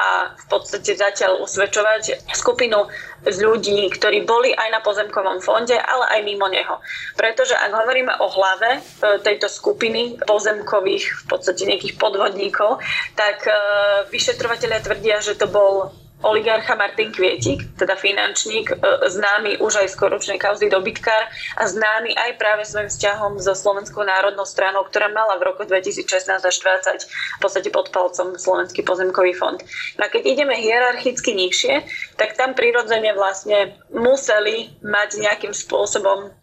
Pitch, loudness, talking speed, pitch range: 210 Hz, -19 LUFS, 140 wpm, 200-235 Hz